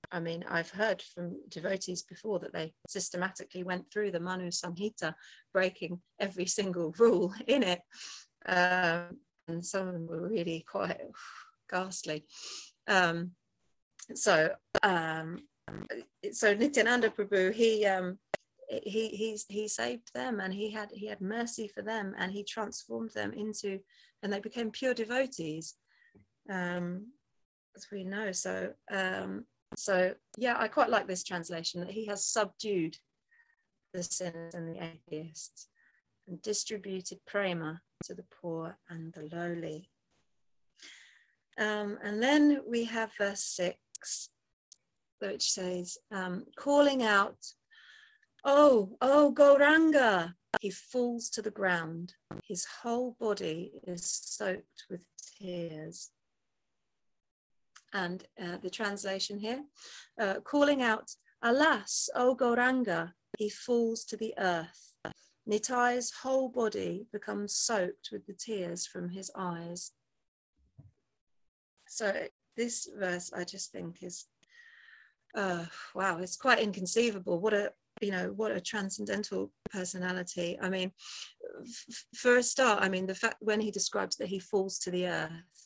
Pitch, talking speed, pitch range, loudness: 195 Hz, 130 wpm, 175-225 Hz, -32 LUFS